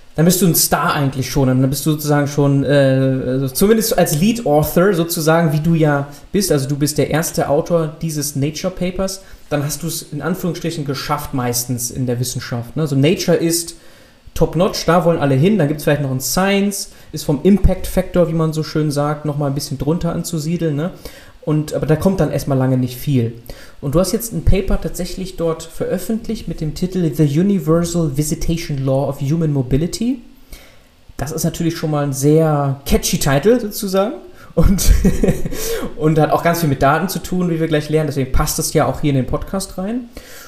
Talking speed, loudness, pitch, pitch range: 200 wpm, -17 LUFS, 160 Hz, 145-175 Hz